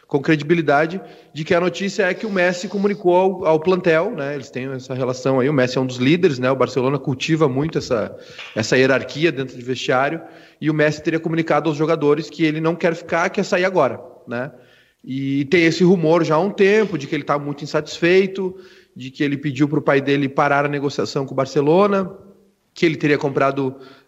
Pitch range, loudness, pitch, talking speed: 135-175 Hz, -19 LUFS, 155 Hz, 210 wpm